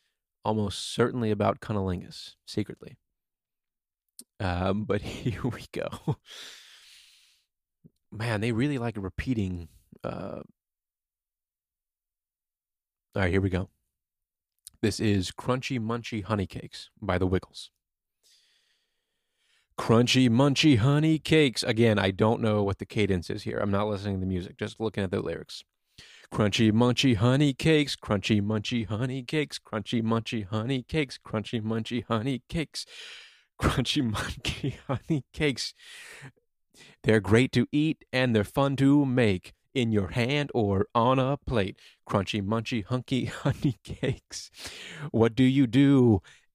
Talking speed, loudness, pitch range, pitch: 130 wpm, -27 LUFS, 100-130 Hz, 115 Hz